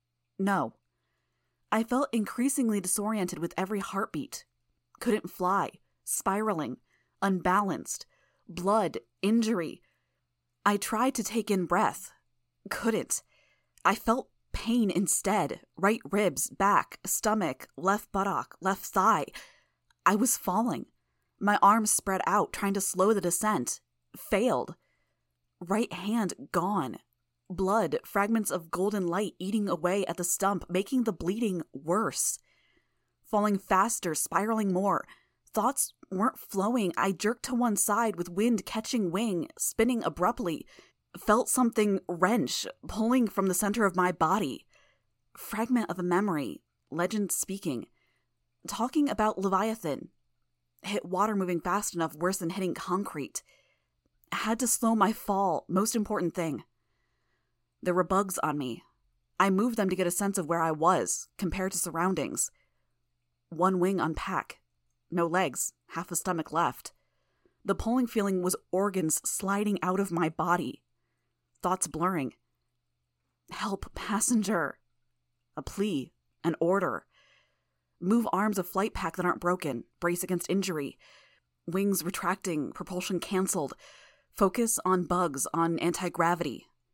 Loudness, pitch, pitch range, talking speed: -29 LUFS, 190 Hz, 170-210 Hz, 125 wpm